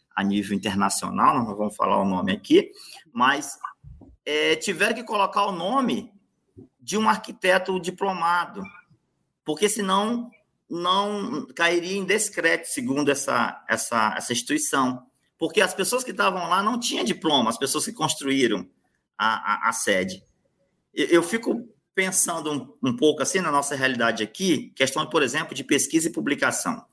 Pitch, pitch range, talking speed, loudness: 175 Hz, 140-205 Hz, 145 wpm, -23 LUFS